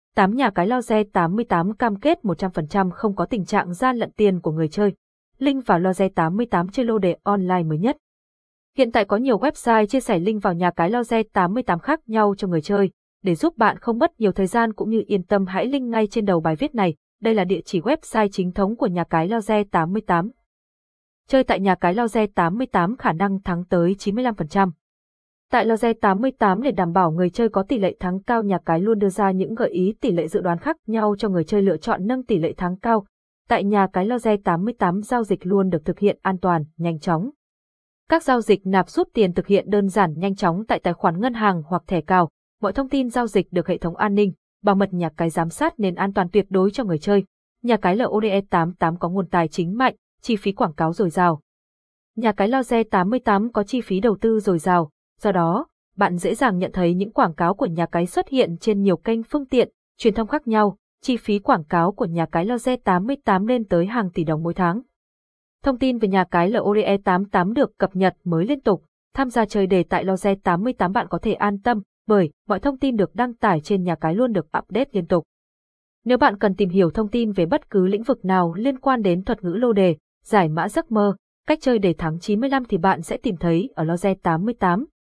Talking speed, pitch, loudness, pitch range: 235 wpm, 200 Hz, -21 LUFS, 180-230 Hz